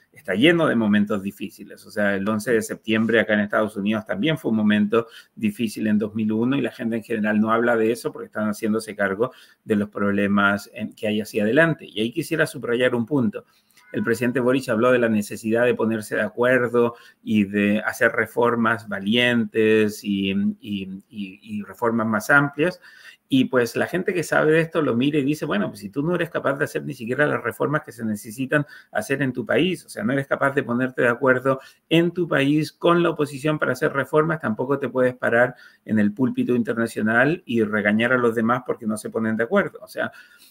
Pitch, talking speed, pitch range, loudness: 115 Hz, 210 wpm, 110-140 Hz, -22 LUFS